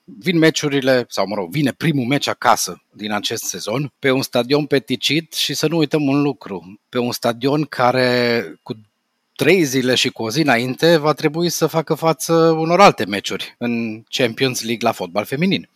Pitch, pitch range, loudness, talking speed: 135 Hz, 120-155 Hz, -18 LUFS, 185 wpm